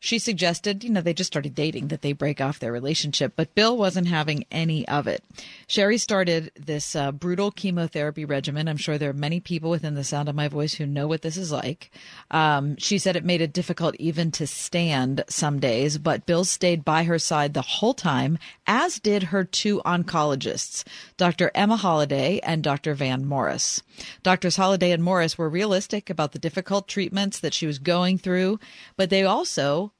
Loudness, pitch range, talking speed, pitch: -24 LUFS, 150-185 Hz, 195 wpm, 165 Hz